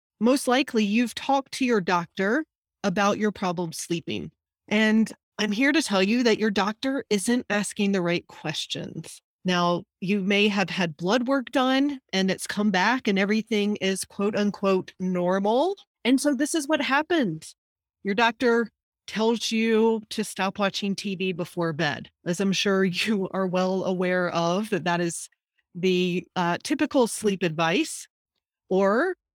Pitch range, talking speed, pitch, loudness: 185-235 Hz, 155 wpm, 205 Hz, -25 LUFS